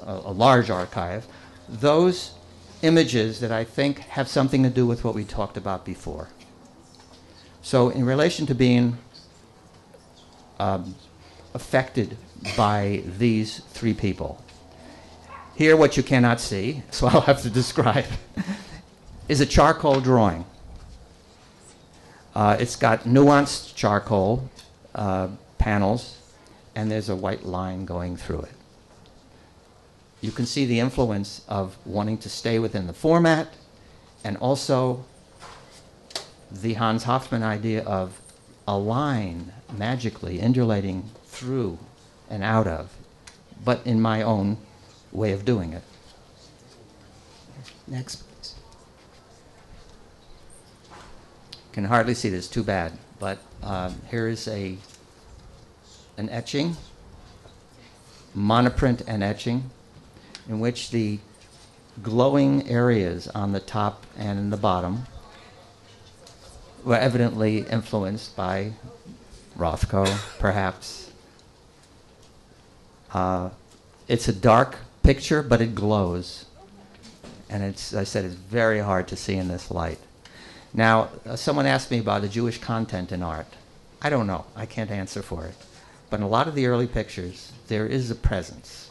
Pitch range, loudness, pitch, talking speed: 95-120 Hz, -24 LUFS, 110 Hz, 120 wpm